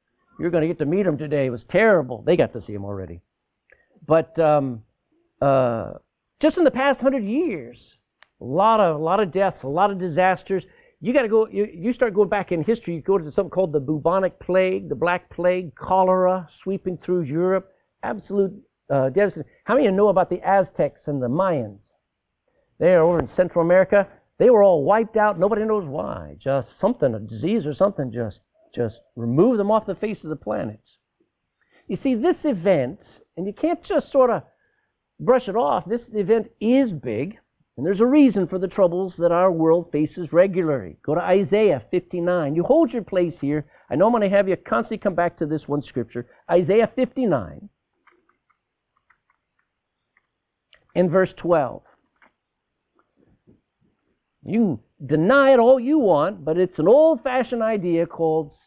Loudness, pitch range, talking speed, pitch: -21 LUFS, 160-215 Hz, 180 wpm, 185 Hz